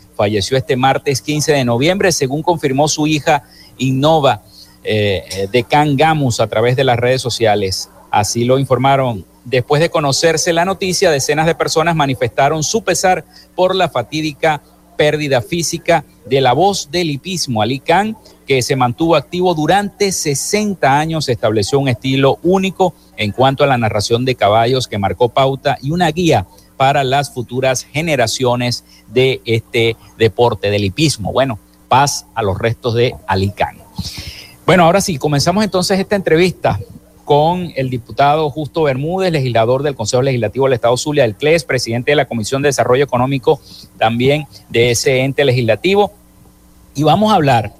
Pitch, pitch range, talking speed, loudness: 135 Hz, 115-155 Hz, 155 wpm, -14 LUFS